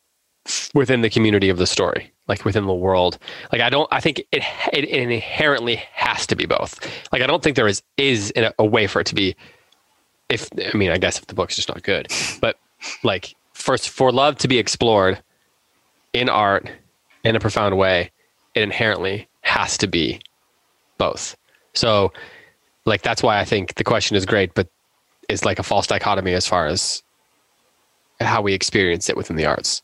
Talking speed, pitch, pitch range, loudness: 185 wpm, 105 Hz, 95-120 Hz, -19 LUFS